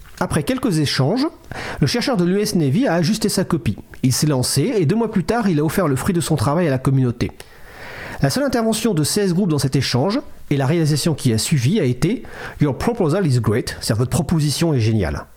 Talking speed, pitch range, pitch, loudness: 225 wpm, 130-195 Hz, 155 Hz, -19 LUFS